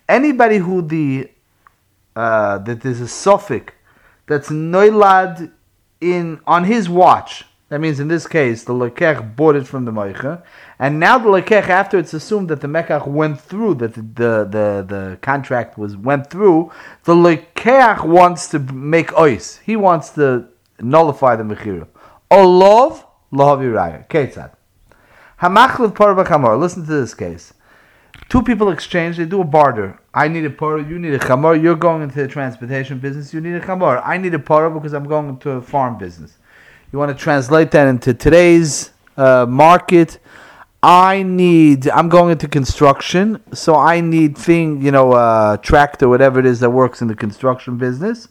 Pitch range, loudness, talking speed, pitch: 130-175 Hz, -14 LUFS, 170 wpm, 150 Hz